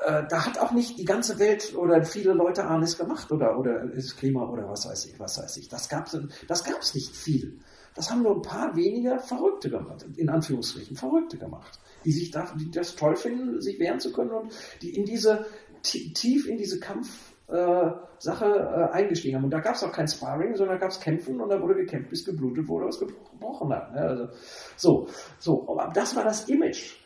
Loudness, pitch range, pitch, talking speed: -27 LUFS, 160-225 Hz, 185 Hz, 210 wpm